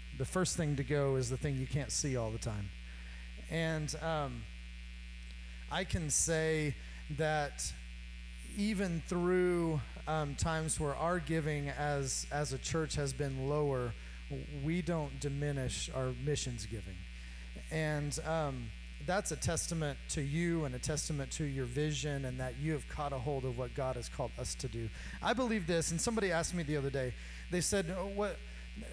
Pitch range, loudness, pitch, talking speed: 120-160 Hz, -36 LUFS, 145 Hz, 170 wpm